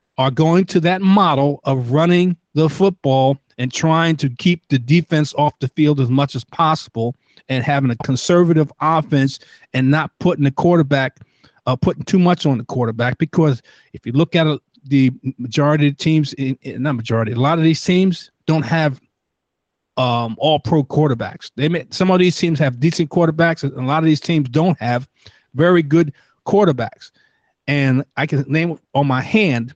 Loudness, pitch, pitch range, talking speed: -17 LUFS, 150 Hz, 135-165 Hz, 180 wpm